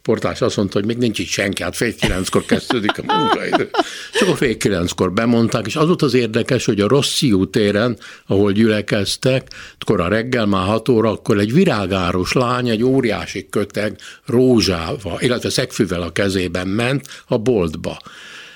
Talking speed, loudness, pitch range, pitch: 165 wpm, -17 LUFS, 100-125 Hz, 110 Hz